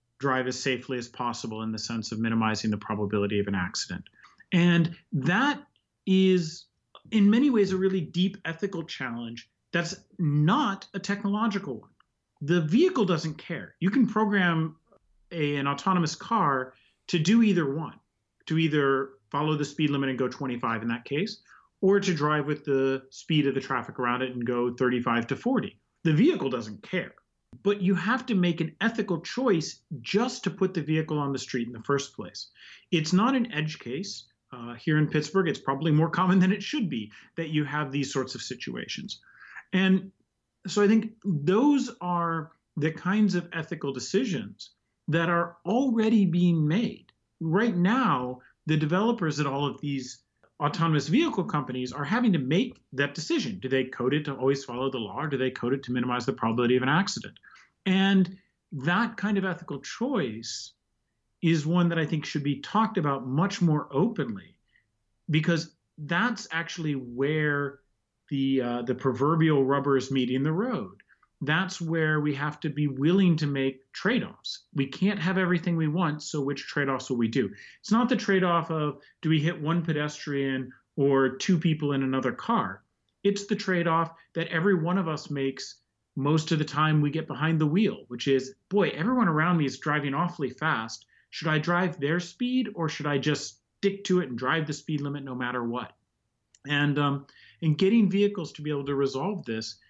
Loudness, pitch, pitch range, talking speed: -27 LUFS, 155 Hz, 135-185 Hz, 185 wpm